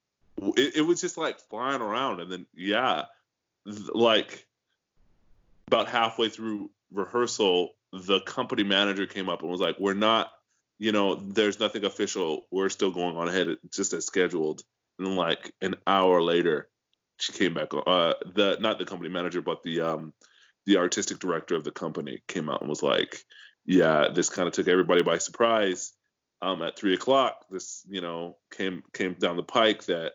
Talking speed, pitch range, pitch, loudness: 175 wpm, 90-110 Hz, 95 Hz, -27 LUFS